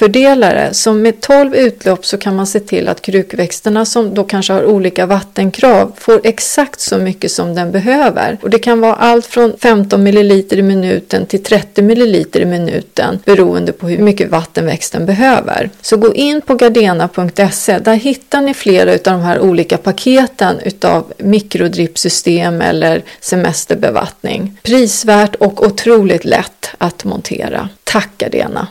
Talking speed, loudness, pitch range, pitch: 155 wpm, -11 LUFS, 190-235 Hz, 205 Hz